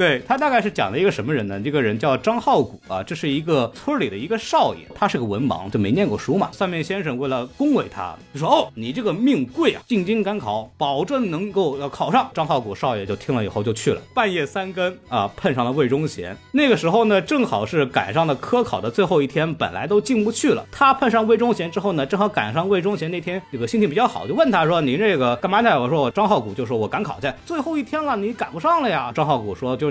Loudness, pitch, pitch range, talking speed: -21 LUFS, 200 Hz, 155-235 Hz, 370 characters per minute